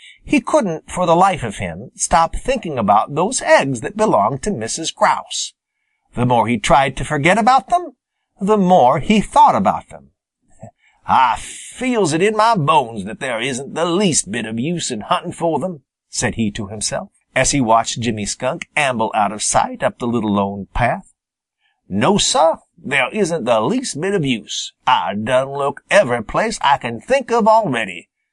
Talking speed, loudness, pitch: 180 wpm, -17 LUFS, 170 Hz